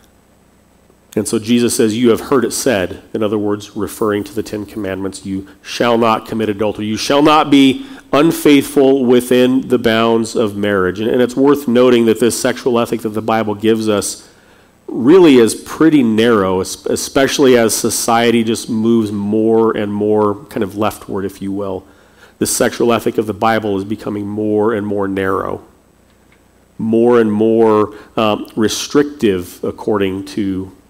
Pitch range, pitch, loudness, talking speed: 105-115 Hz, 110 Hz, -14 LUFS, 160 wpm